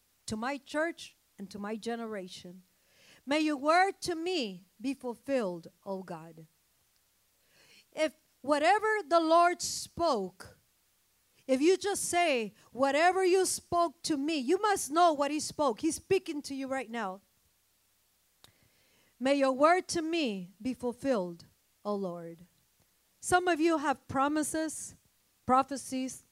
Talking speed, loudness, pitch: 130 wpm, -30 LUFS, 270 Hz